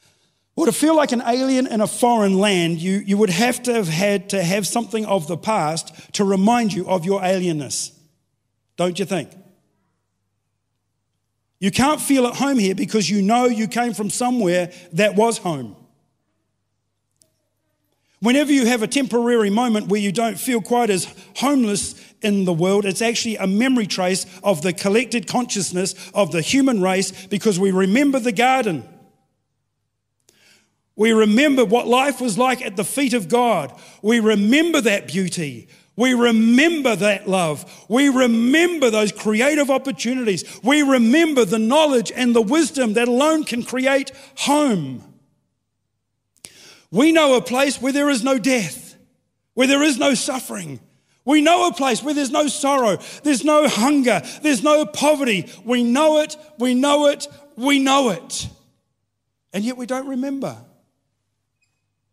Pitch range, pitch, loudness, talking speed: 185-260 Hz, 225 Hz, -18 LUFS, 155 wpm